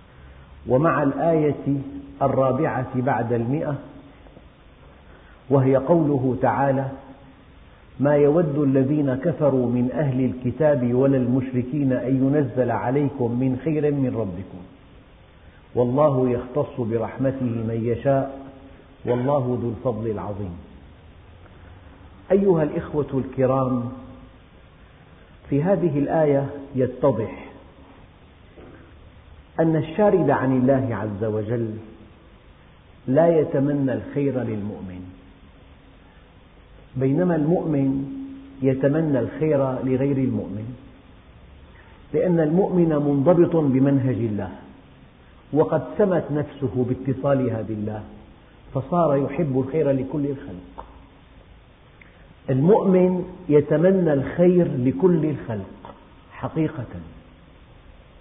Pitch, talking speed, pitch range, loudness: 130 Hz, 80 wpm, 105-145 Hz, -22 LUFS